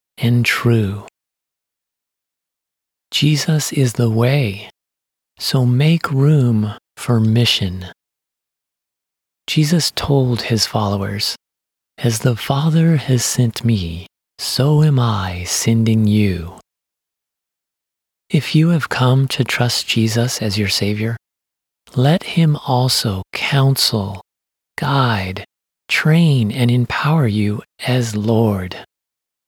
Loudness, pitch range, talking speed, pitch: -16 LUFS, 105-140 Hz, 95 wpm, 120 Hz